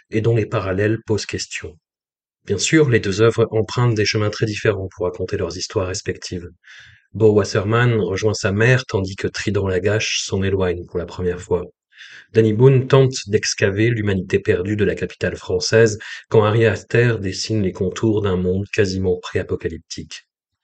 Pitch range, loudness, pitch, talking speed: 95-115 Hz, -19 LUFS, 105 Hz, 165 wpm